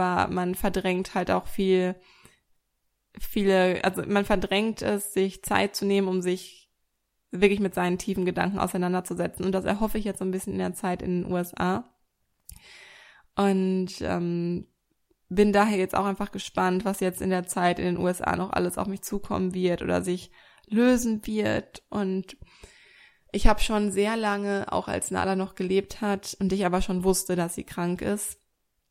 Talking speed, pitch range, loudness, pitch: 175 wpm, 180-205 Hz, -27 LUFS, 190 Hz